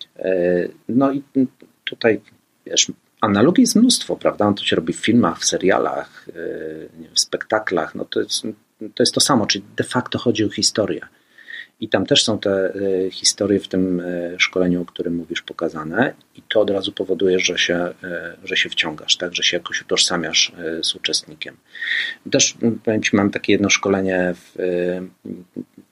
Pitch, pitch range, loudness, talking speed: 95 Hz, 90-130 Hz, -19 LUFS, 155 wpm